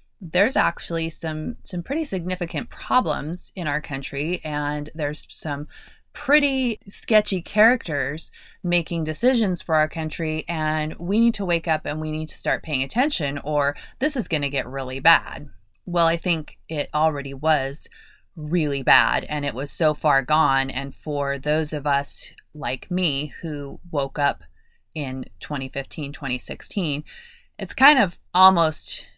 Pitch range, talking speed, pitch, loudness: 145-175 Hz, 150 wpm, 155 Hz, -23 LUFS